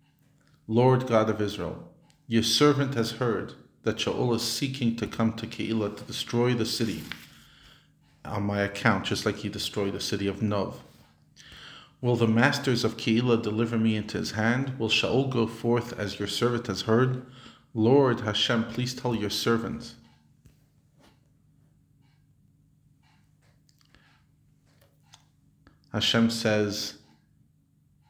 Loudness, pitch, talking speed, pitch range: -27 LUFS, 120 Hz, 125 wpm, 110-145 Hz